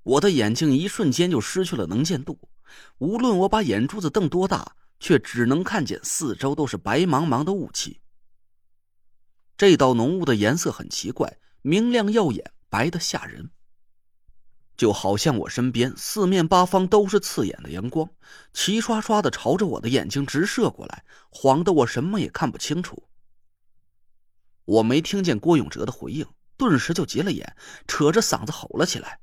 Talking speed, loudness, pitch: 250 characters per minute, -22 LUFS, 140 Hz